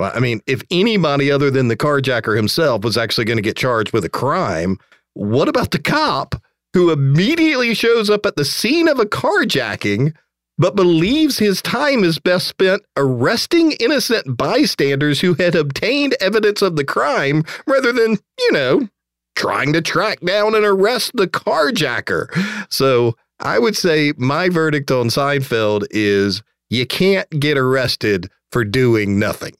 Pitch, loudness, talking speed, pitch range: 150 Hz, -16 LUFS, 155 wpm, 125-205 Hz